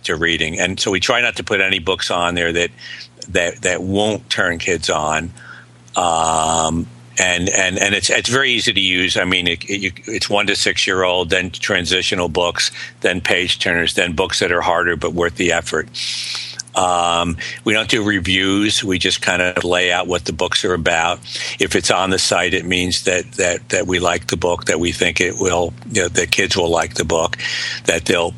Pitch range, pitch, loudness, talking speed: 85-95 Hz, 90 Hz, -16 LUFS, 210 wpm